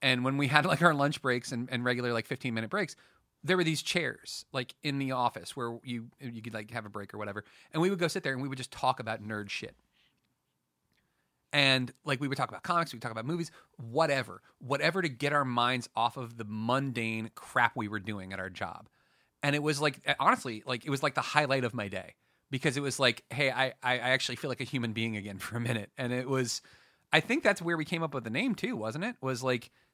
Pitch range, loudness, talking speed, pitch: 115-145 Hz, -31 LUFS, 250 wpm, 130 Hz